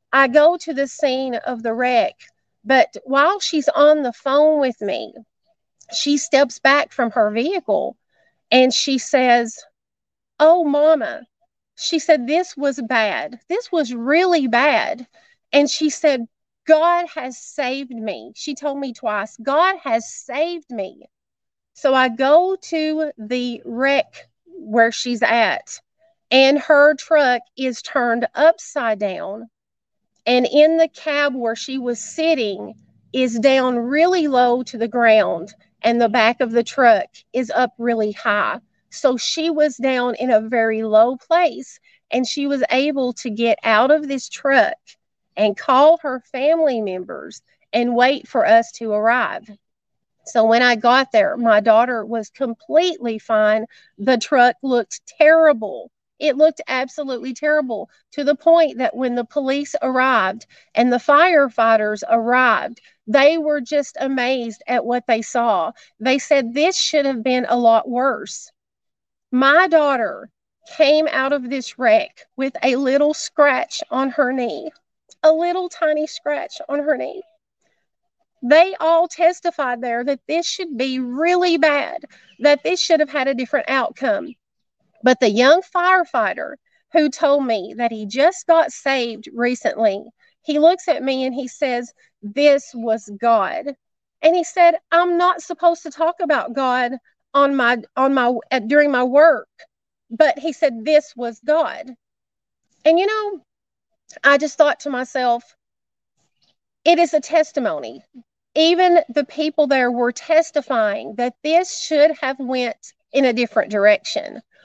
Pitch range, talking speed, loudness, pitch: 245-315 Hz, 150 wpm, -18 LUFS, 275 Hz